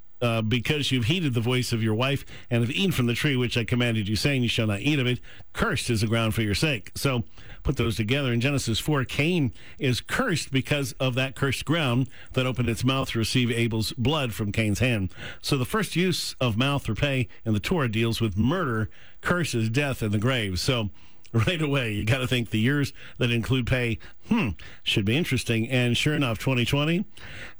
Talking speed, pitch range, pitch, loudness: 215 wpm, 110-135 Hz, 120 Hz, -25 LUFS